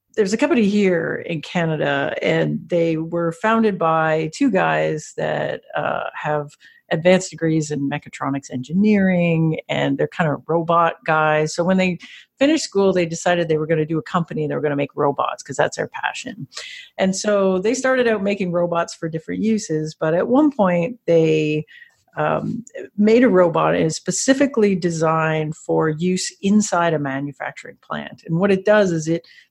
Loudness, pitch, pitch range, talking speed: -19 LUFS, 170 Hz, 155-200 Hz, 175 wpm